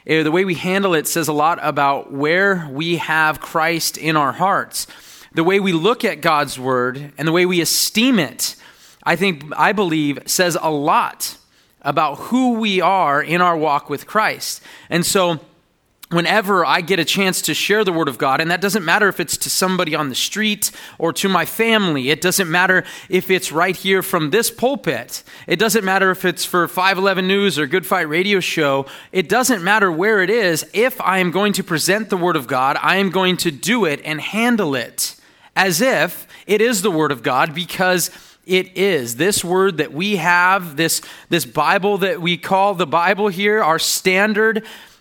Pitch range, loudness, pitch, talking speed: 160-195 Hz, -17 LUFS, 180 Hz, 195 wpm